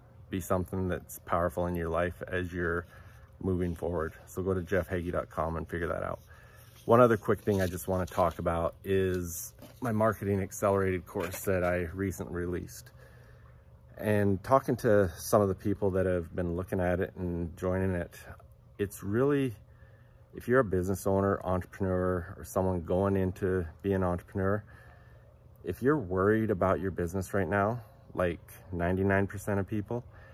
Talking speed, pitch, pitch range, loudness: 160 wpm, 95 Hz, 90-105 Hz, -31 LUFS